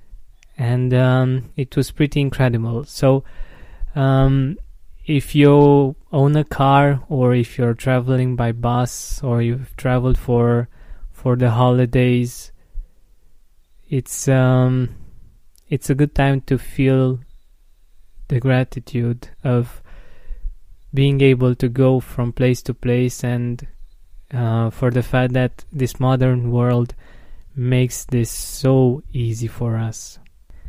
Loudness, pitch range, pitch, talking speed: -18 LUFS, 115-130 Hz, 125 Hz, 115 wpm